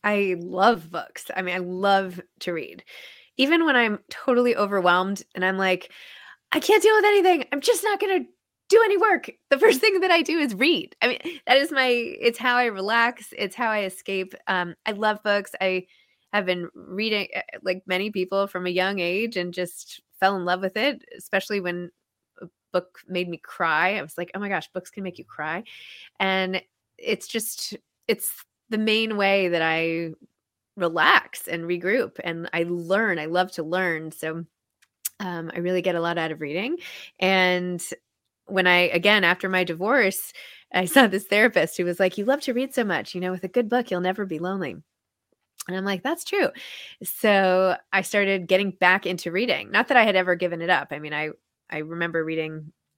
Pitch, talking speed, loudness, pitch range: 190 Hz, 200 wpm, -23 LUFS, 180-230 Hz